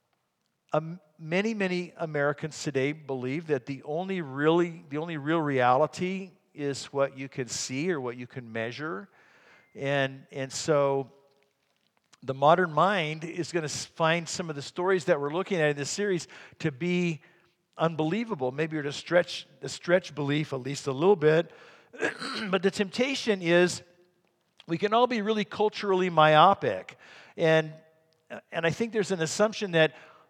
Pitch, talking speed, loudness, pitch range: 160 Hz, 155 wpm, -28 LUFS, 140-180 Hz